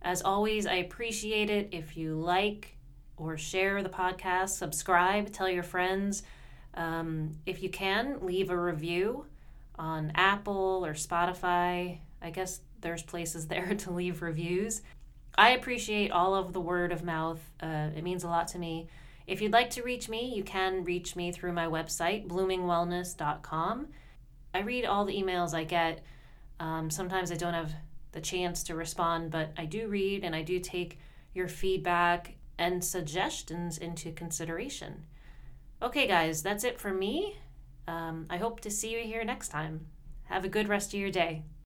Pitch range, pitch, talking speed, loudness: 165-190 Hz, 175 Hz, 165 wpm, -32 LUFS